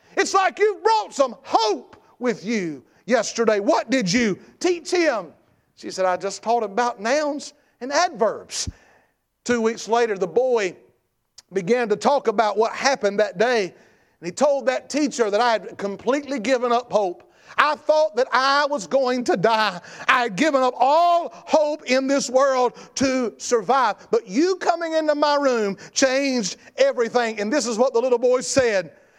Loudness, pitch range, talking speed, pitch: -21 LUFS, 225-290 Hz, 175 wpm, 250 Hz